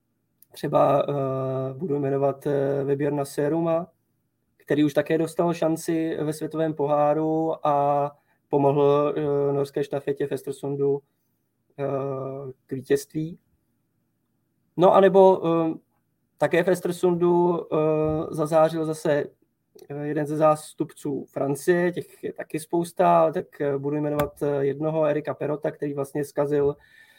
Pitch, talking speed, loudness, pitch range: 150 Hz, 105 wpm, -24 LUFS, 140-160 Hz